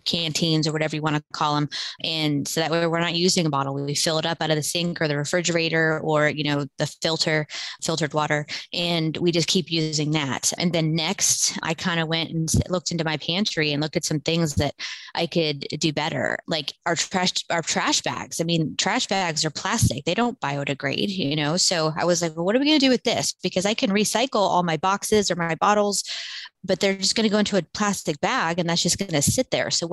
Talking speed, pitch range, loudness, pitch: 245 wpm, 155-185 Hz, -23 LUFS, 165 Hz